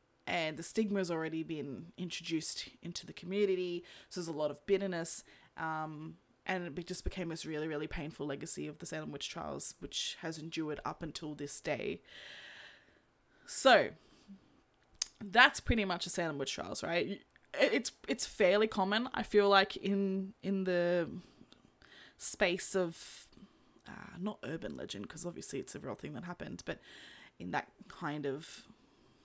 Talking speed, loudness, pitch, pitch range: 155 wpm, -35 LUFS, 175 Hz, 155-195 Hz